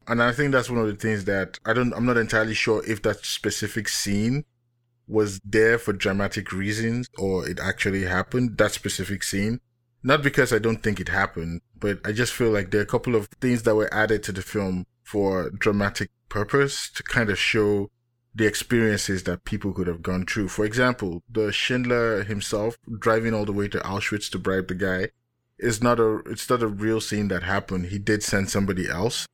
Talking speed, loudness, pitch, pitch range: 205 wpm, -24 LUFS, 105 Hz, 100-120 Hz